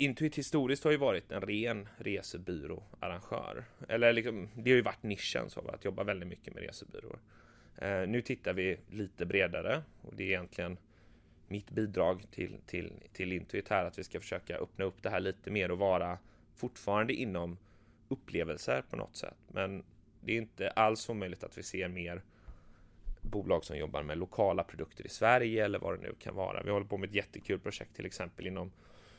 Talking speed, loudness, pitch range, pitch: 190 wpm, -36 LUFS, 90-110 Hz, 100 Hz